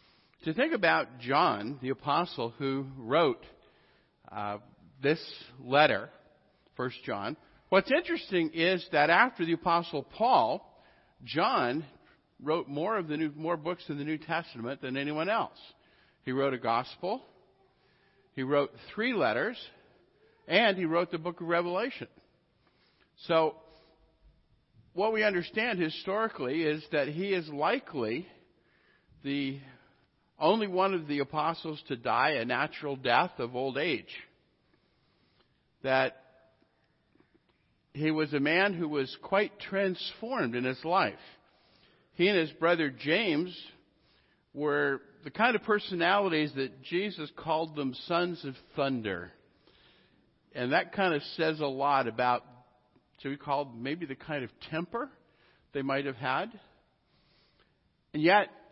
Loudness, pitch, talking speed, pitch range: -30 LUFS, 155 Hz, 130 wpm, 135-175 Hz